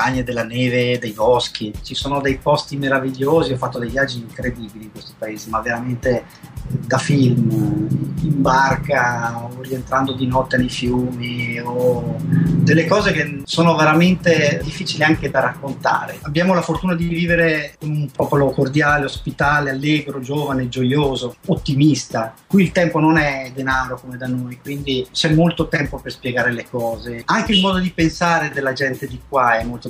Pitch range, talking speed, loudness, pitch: 125-155 Hz, 165 wpm, -18 LUFS, 135 Hz